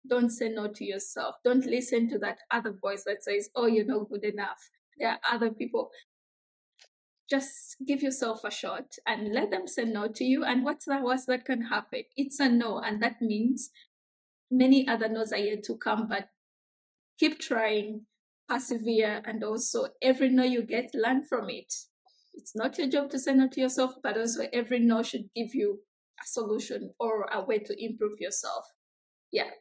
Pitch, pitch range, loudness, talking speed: 240 Hz, 220-270 Hz, -29 LUFS, 190 wpm